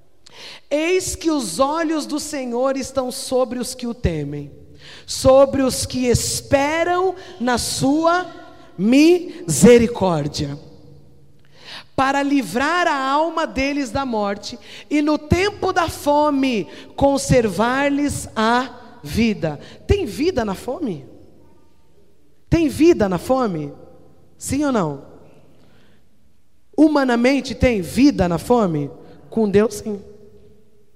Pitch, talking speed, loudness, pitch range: 260 Hz, 105 wpm, -19 LUFS, 210-295 Hz